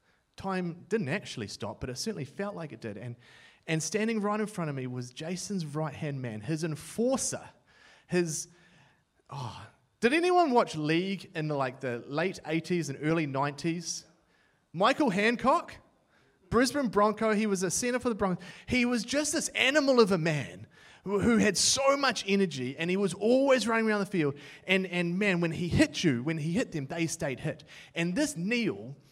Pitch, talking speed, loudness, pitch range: 175 Hz, 185 wpm, -29 LUFS, 155-220 Hz